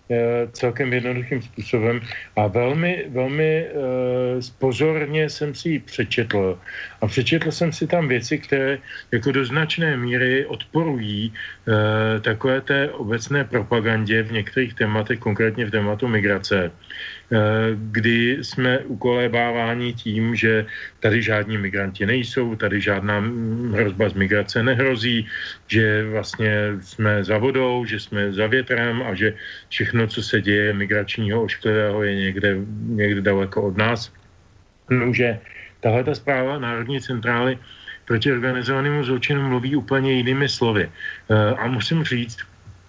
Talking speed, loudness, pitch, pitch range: 125 wpm, -21 LUFS, 115 Hz, 105-130 Hz